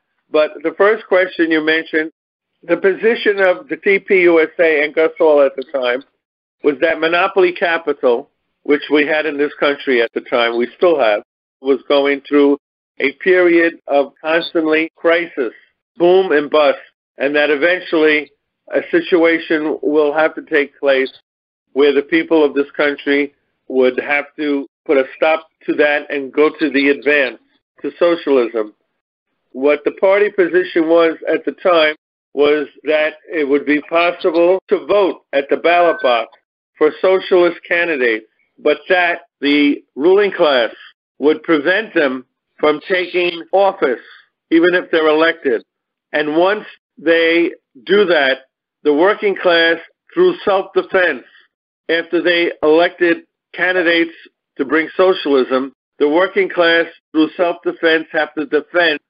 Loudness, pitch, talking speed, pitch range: -15 LUFS, 160 Hz, 140 wpm, 145-175 Hz